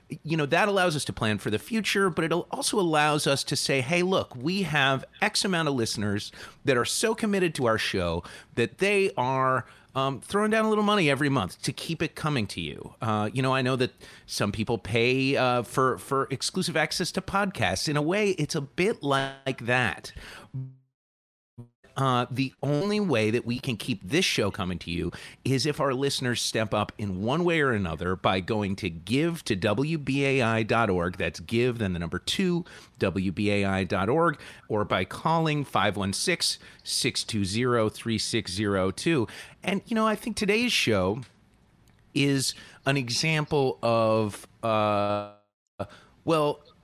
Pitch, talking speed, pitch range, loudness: 130 Hz, 165 wpm, 105-155 Hz, -26 LUFS